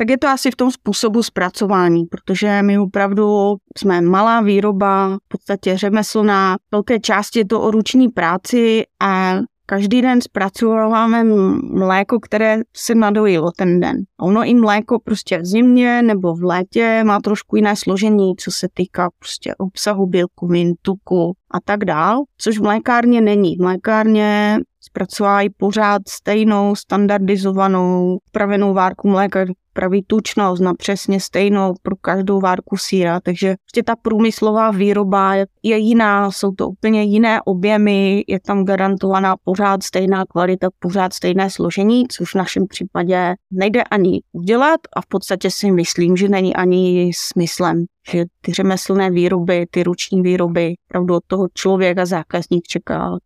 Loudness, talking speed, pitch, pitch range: -16 LUFS, 145 wpm, 195 Hz, 185-215 Hz